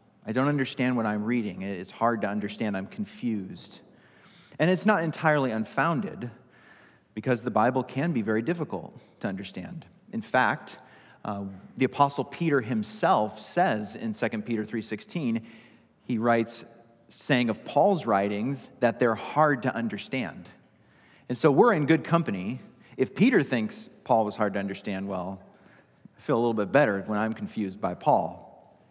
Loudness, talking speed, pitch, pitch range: -27 LUFS, 155 wpm, 115 Hz, 105-140 Hz